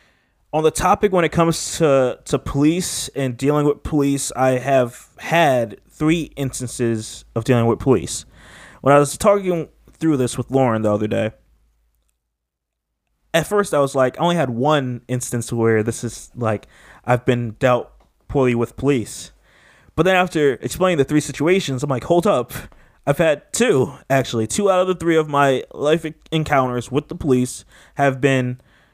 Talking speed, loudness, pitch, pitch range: 170 wpm, -19 LUFS, 135 Hz, 120-155 Hz